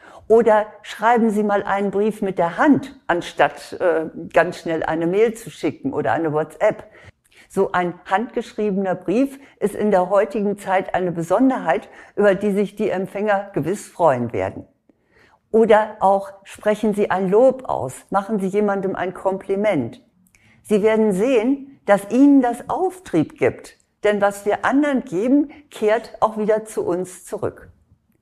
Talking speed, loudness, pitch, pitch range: 150 wpm, -20 LUFS, 205 Hz, 190-225 Hz